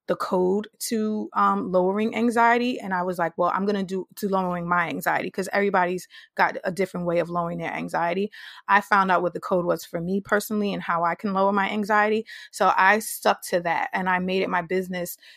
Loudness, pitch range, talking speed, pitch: -24 LUFS, 180-205 Hz, 220 wpm, 190 Hz